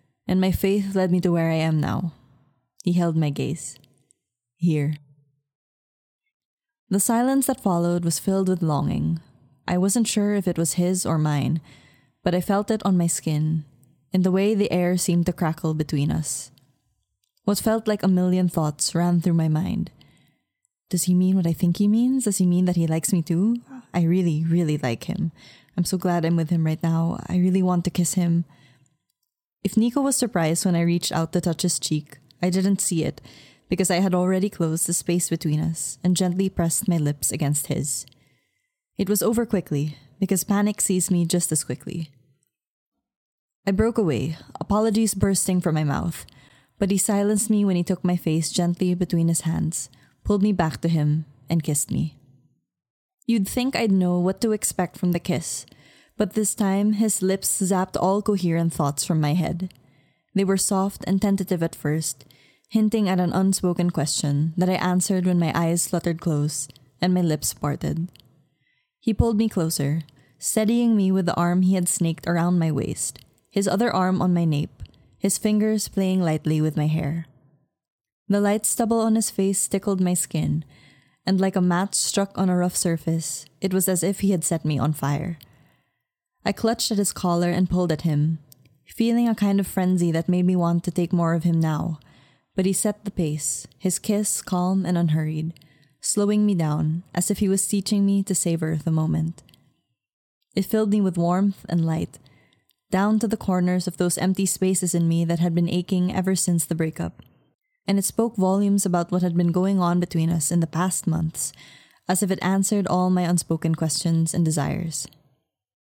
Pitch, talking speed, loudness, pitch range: 175 Hz, 190 wpm, -23 LUFS, 155-190 Hz